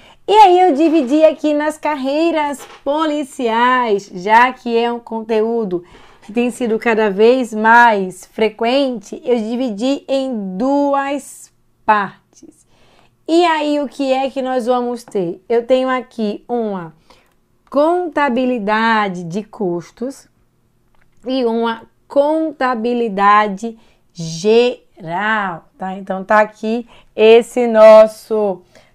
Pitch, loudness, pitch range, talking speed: 235 Hz, -15 LUFS, 215-270 Hz, 105 wpm